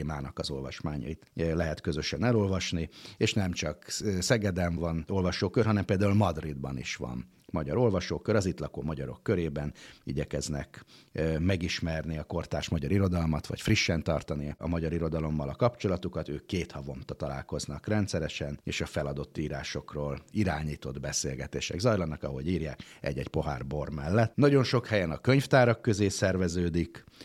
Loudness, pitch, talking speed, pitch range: -30 LUFS, 85 Hz, 140 wpm, 75-100 Hz